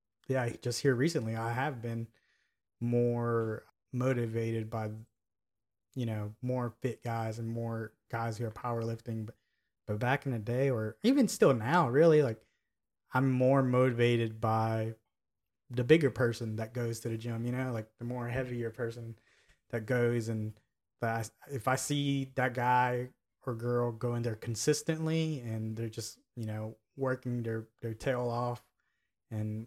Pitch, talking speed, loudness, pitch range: 120 Hz, 160 wpm, -33 LUFS, 110-130 Hz